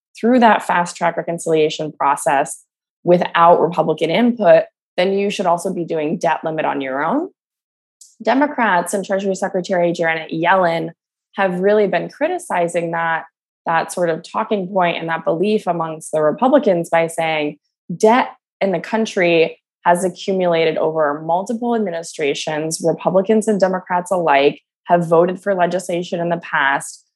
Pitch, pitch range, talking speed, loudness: 175 Hz, 165-200 Hz, 140 wpm, -17 LUFS